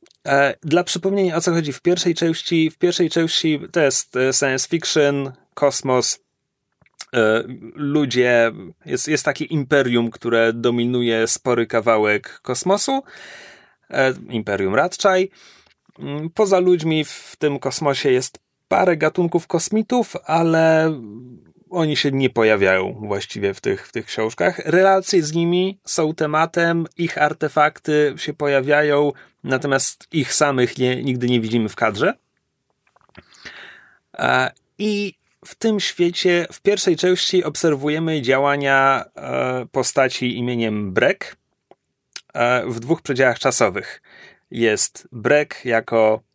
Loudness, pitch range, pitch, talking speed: -19 LUFS, 125-170 Hz, 150 Hz, 110 wpm